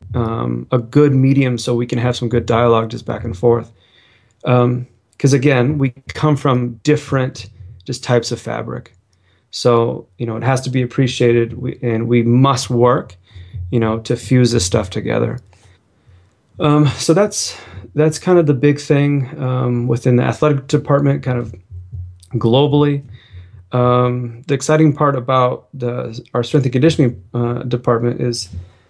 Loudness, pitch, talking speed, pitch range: -16 LUFS, 120 Hz, 155 wpm, 115-135 Hz